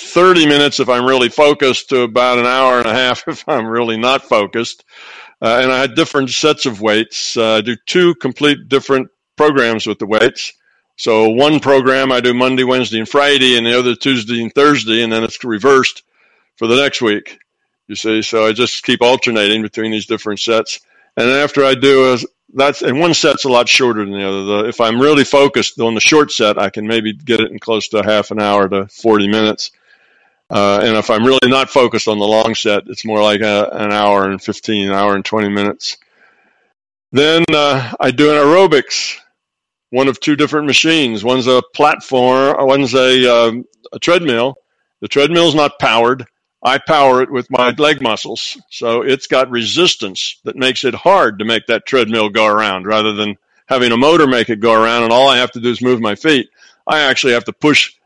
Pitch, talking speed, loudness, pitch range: 125 Hz, 205 wpm, -12 LUFS, 110-135 Hz